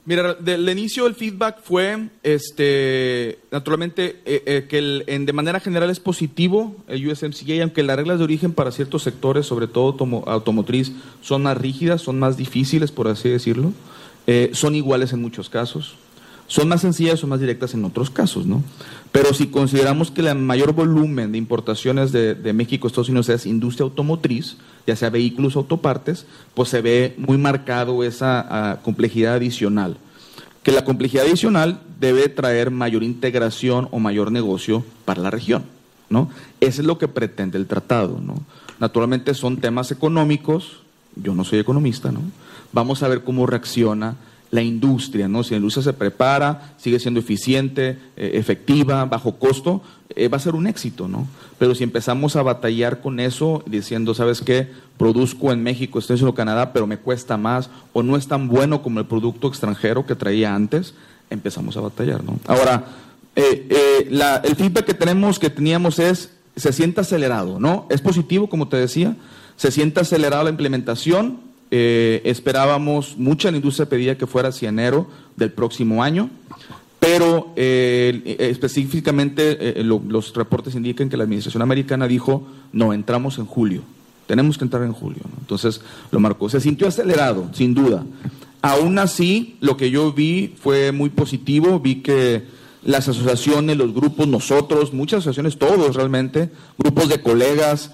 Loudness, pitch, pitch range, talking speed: -19 LUFS, 135 Hz, 120-150 Hz, 170 wpm